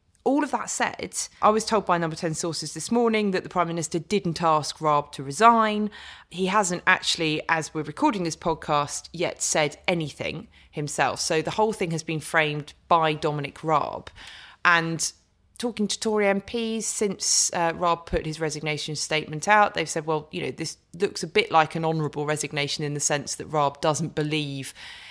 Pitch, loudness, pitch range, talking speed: 165 Hz, -25 LUFS, 155-195 Hz, 185 wpm